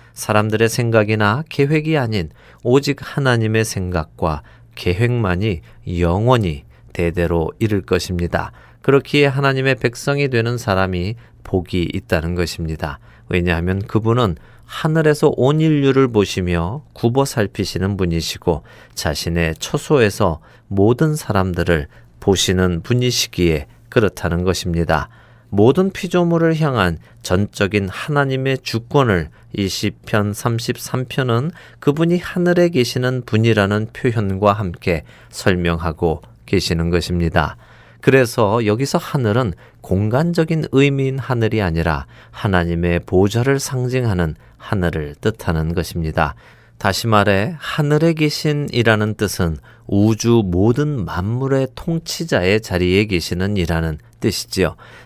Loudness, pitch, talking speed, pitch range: -18 LUFS, 110 Hz, 275 characters per minute, 90-125 Hz